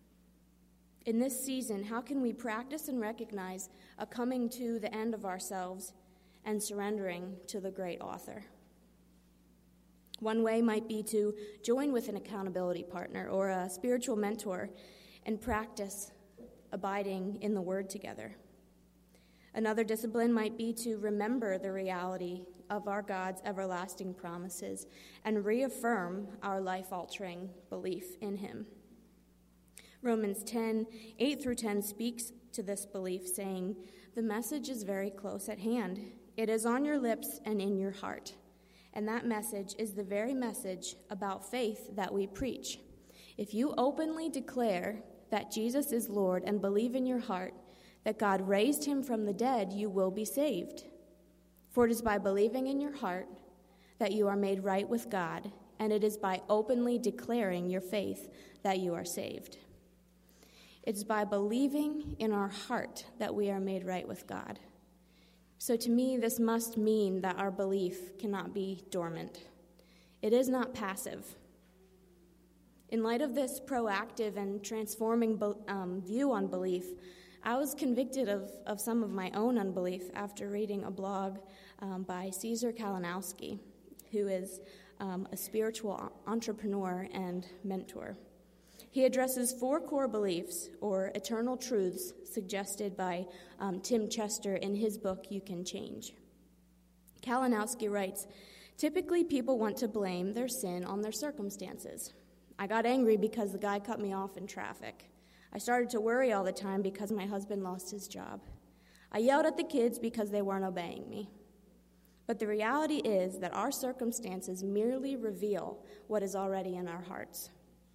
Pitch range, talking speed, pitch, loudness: 190-230 Hz, 150 wpm, 205 Hz, -36 LUFS